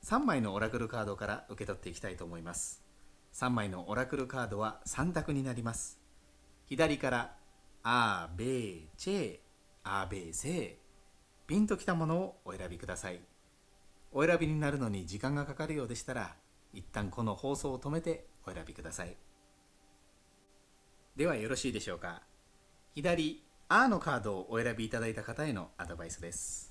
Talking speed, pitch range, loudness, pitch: 335 characters per minute, 95-130 Hz, -36 LUFS, 100 Hz